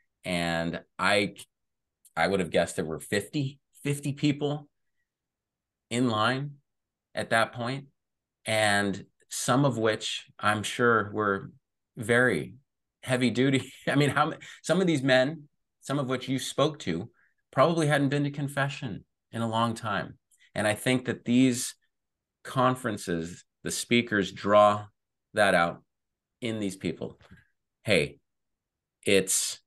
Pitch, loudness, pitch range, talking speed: 120 Hz, -27 LUFS, 105-140 Hz, 130 wpm